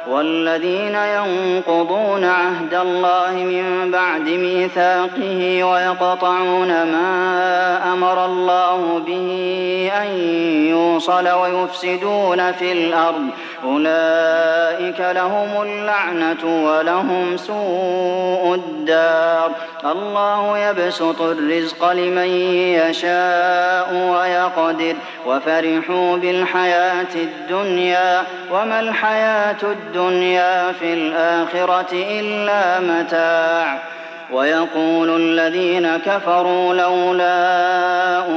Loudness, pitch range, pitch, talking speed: -17 LUFS, 165-180 Hz, 180 Hz, 70 wpm